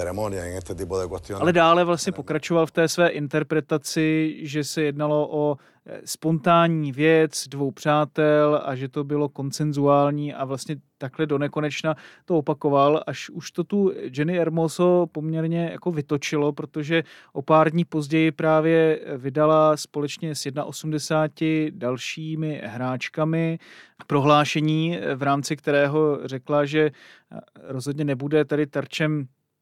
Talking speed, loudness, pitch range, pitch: 120 wpm, -23 LUFS, 145-160 Hz, 150 Hz